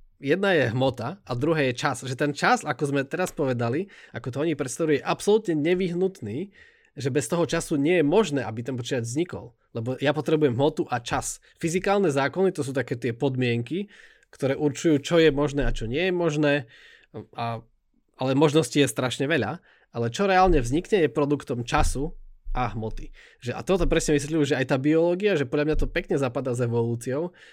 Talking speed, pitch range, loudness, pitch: 190 wpm, 130-165 Hz, -25 LUFS, 145 Hz